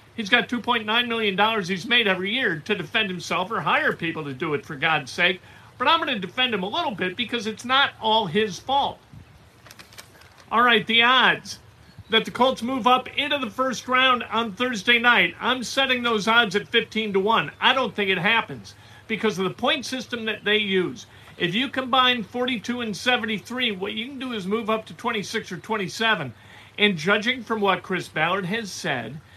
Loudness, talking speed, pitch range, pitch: -22 LUFS, 200 wpm, 195-245 Hz, 220 Hz